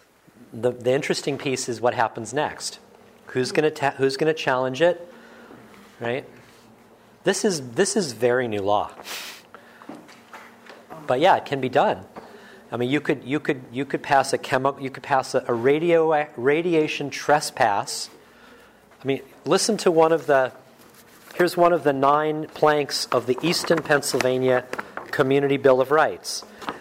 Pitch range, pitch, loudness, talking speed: 130-160 Hz, 145 Hz, -22 LUFS, 150 wpm